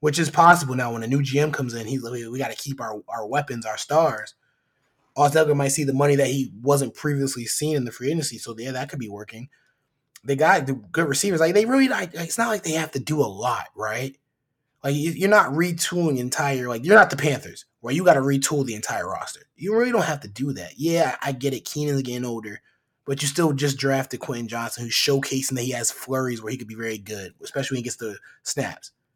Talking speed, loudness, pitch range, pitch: 245 wpm, -23 LUFS, 120-150 Hz, 135 Hz